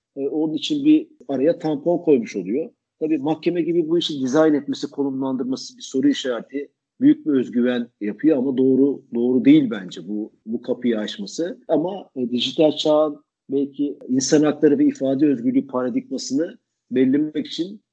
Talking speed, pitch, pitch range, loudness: 145 wpm, 145 Hz, 130-170 Hz, -21 LUFS